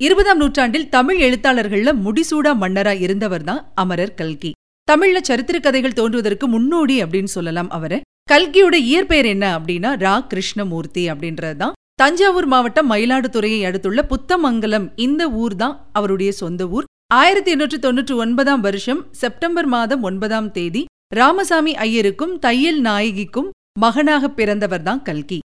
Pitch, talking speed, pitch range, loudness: 245 Hz, 125 wpm, 200-295 Hz, -17 LUFS